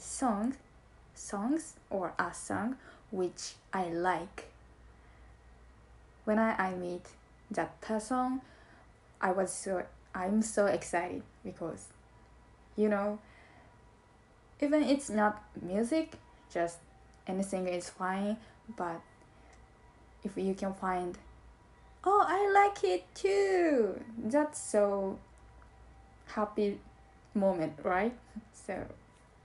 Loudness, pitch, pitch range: -33 LUFS, 210 Hz, 185-250 Hz